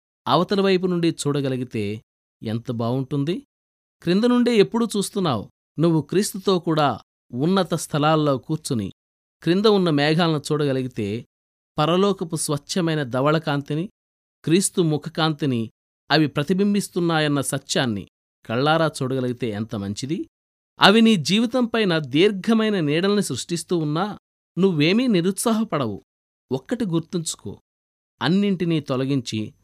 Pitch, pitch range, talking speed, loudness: 155 Hz, 125-185 Hz, 90 wpm, -22 LUFS